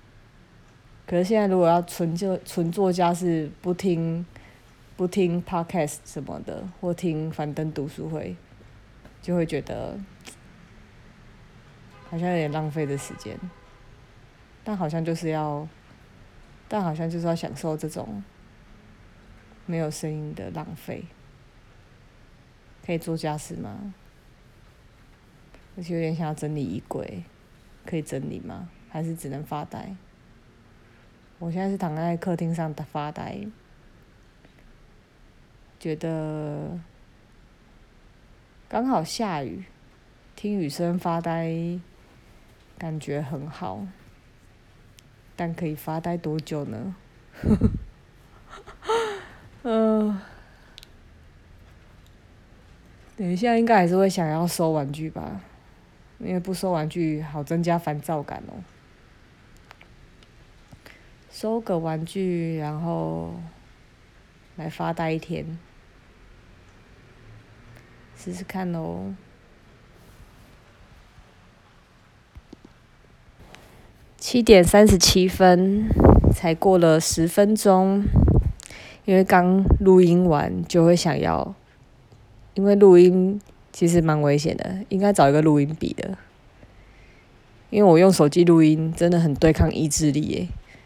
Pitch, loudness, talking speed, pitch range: 160 Hz, -22 LUFS, 155 characters per minute, 125-180 Hz